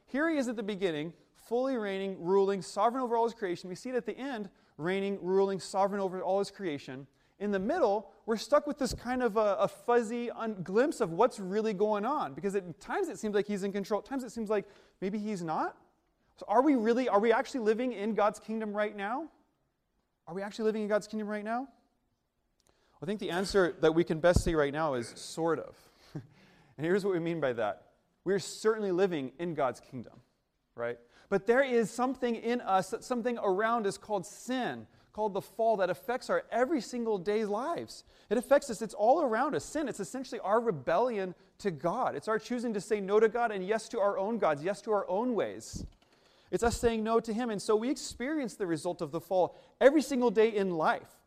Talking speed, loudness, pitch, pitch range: 220 wpm, -31 LUFS, 210 Hz, 190-235 Hz